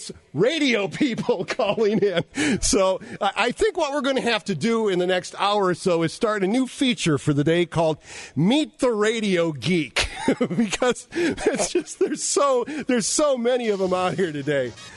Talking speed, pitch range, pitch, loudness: 185 wpm, 180-260 Hz, 215 Hz, -22 LUFS